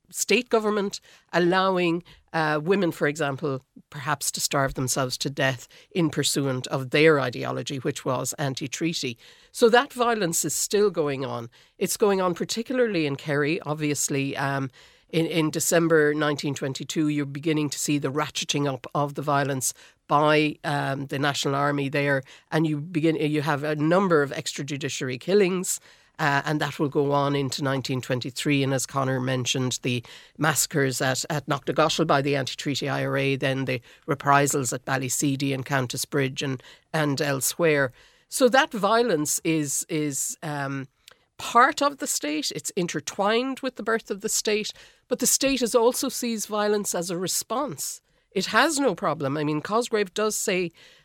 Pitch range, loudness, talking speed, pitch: 140-180 Hz, -24 LUFS, 160 wpm, 150 Hz